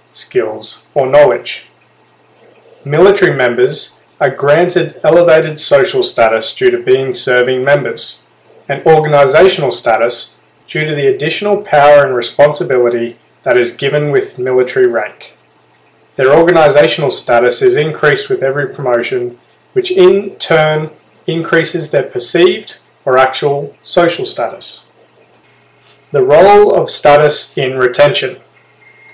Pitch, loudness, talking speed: 165 Hz, -10 LUFS, 115 wpm